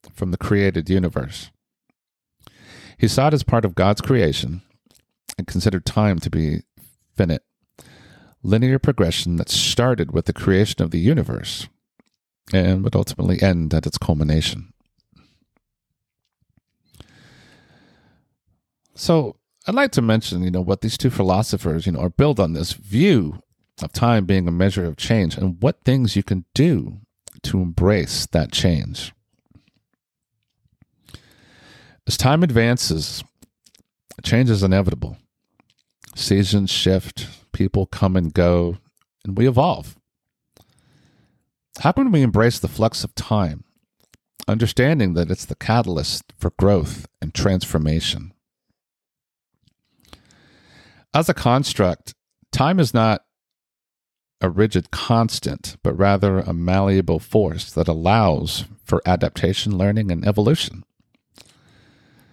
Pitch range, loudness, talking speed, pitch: 90-115 Hz, -20 LUFS, 120 wpm, 100 Hz